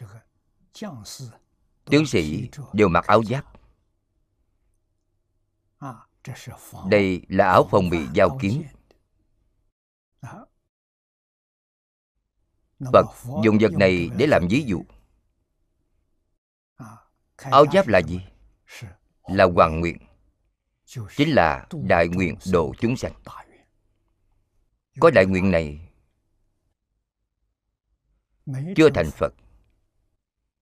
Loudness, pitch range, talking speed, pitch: -20 LUFS, 90-105 Hz, 80 wpm, 100 Hz